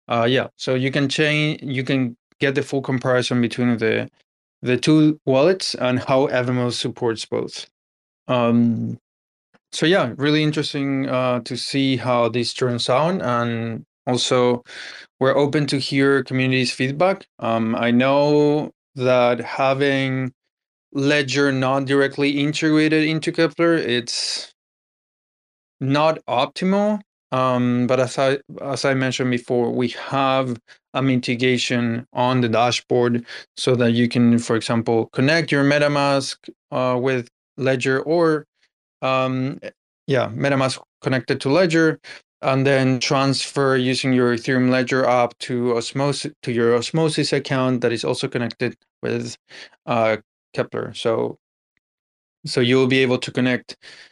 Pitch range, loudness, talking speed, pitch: 120-140 Hz, -20 LUFS, 130 wpm, 130 Hz